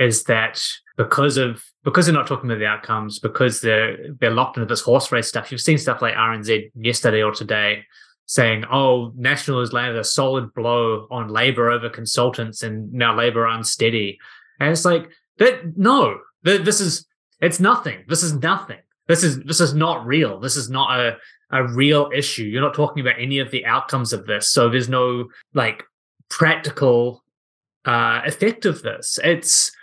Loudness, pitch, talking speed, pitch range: -19 LUFS, 125 Hz, 180 wpm, 115-150 Hz